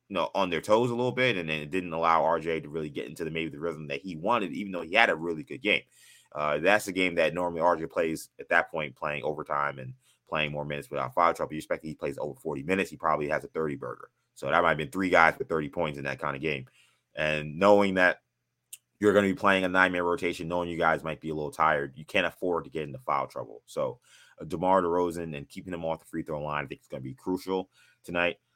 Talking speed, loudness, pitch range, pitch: 270 wpm, -28 LUFS, 75-90 Hz, 80 Hz